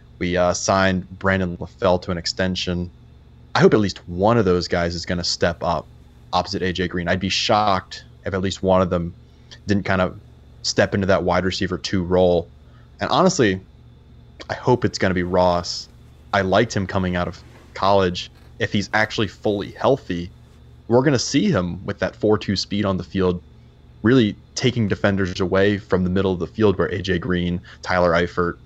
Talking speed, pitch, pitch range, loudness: 190 wpm, 90 Hz, 85-95 Hz, -21 LUFS